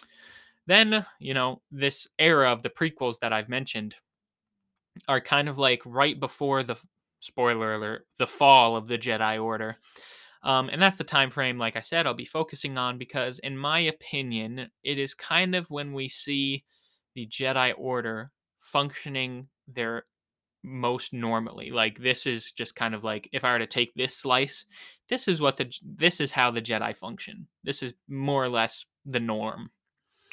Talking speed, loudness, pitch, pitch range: 175 wpm, -26 LUFS, 130 Hz, 115-140 Hz